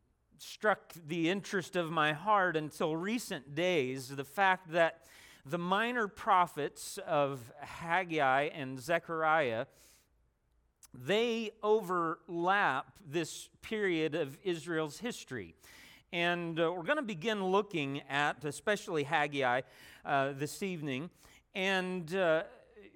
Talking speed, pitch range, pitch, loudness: 100 wpm, 145-190 Hz, 170 Hz, -33 LUFS